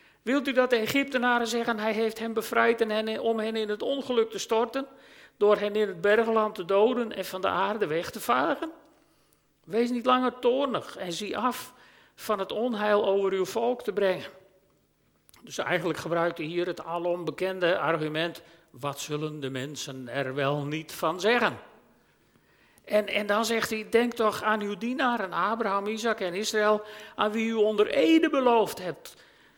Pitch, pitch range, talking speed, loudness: 210 Hz, 175-235 Hz, 175 wpm, -27 LUFS